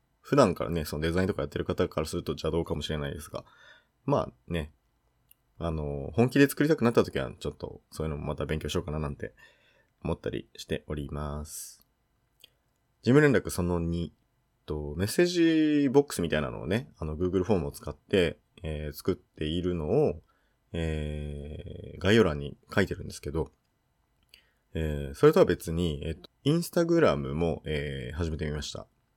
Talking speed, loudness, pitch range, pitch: 360 characters per minute, -29 LUFS, 75-105 Hz, 80 Hz